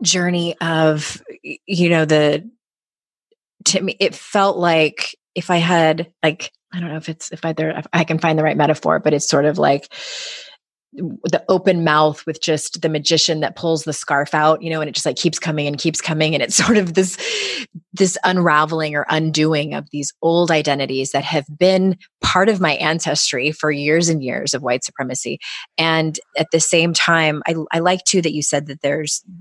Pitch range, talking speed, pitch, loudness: 150-175 Hz, 200 wpm, 160 Hz, -17 LUFS